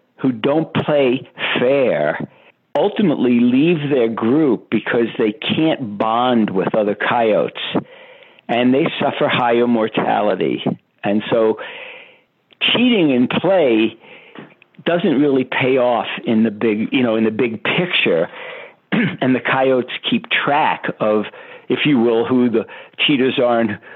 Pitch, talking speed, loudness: 130 Hz, 130 wpm, -17 LUFS